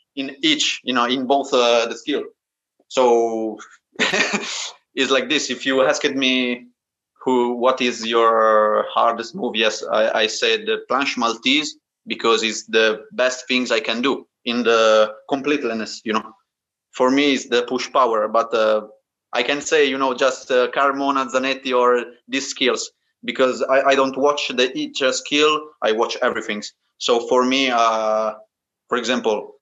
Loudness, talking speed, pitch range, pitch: -19 LUFS, 160 wpm, 115-140 Hz, 125 Hz